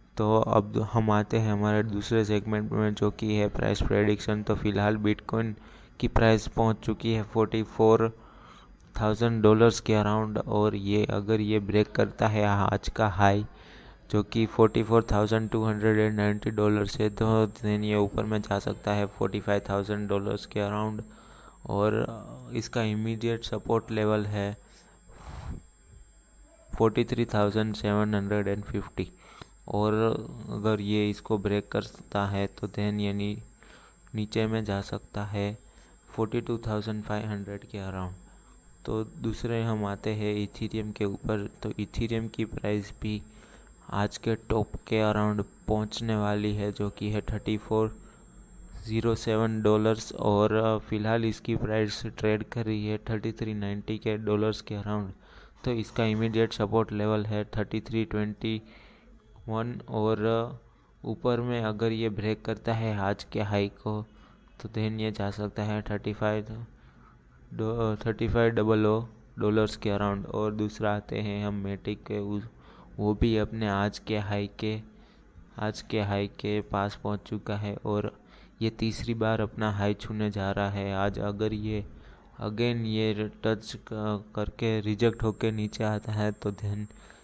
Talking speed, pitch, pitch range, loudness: 145 wpm, 105 Hz, 105-110 Hz, -29 LUFS